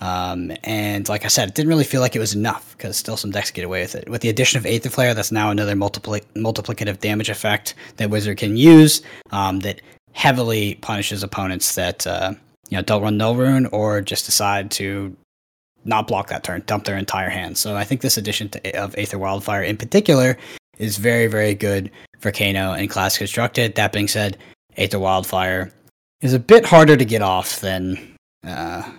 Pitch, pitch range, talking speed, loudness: 105 Hz, 100-115 Hz, 200 wpm, -18 LUFS